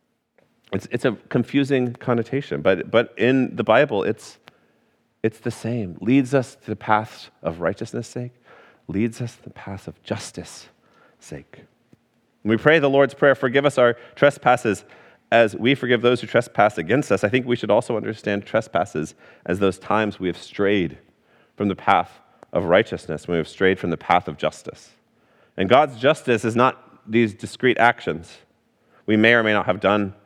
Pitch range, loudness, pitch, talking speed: 105-125 Hz, -21 LUFS, 115 Hz, 180 wpm